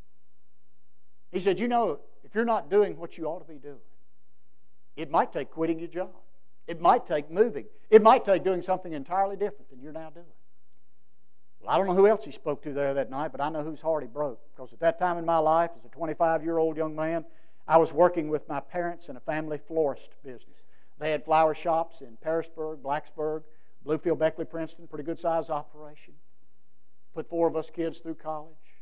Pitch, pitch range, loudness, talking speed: 155 Hz, 140-165 Hz, -27 LUFS, 200 wpm